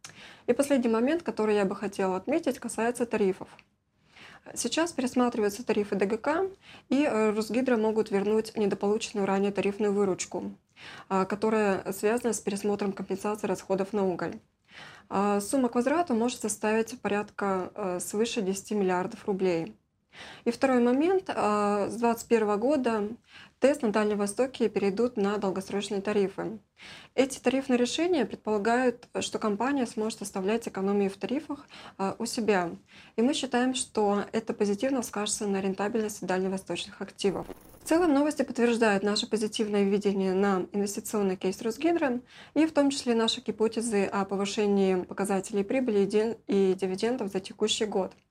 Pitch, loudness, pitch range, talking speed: 215 Hz, -28 LUFS, 200-240 Hz, 130 wpm